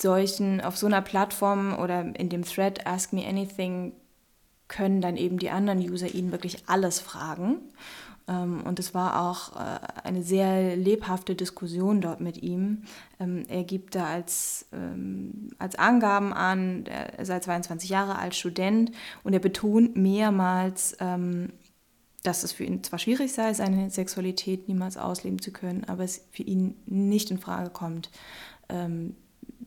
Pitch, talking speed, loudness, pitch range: 185 Hz, 145 wpm, -28 LUFS, 180-200 Hz